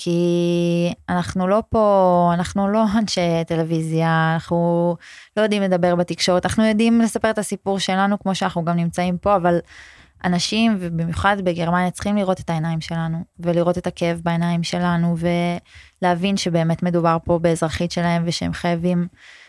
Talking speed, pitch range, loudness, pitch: 140 wpm, 170-195 Hz, -20 LUFS, 175 Hz